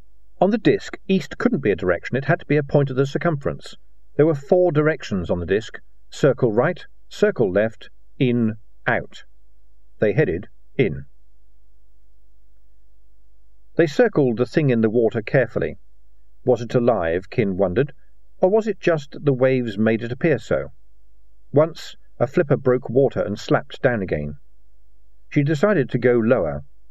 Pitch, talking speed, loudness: 115 Hz, 160 wpm, -21 LUFS